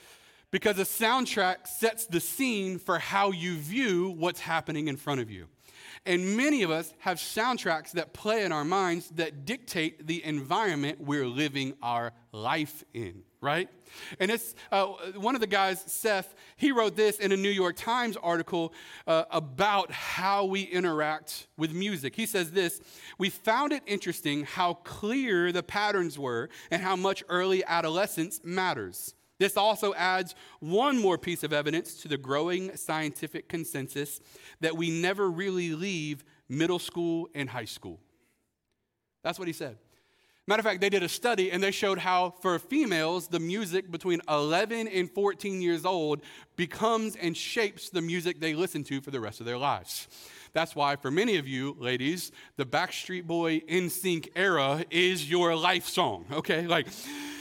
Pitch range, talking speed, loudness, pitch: 155-195 Hz, 165 wpm, -29 LUFS, 175 Hz